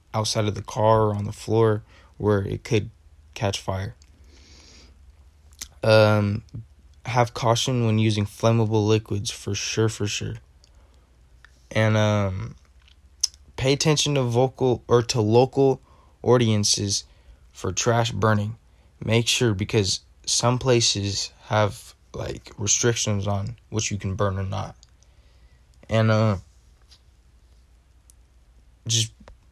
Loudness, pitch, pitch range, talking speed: -23 LUFS, 105 Hz, 75-115 Hz, 110 wpm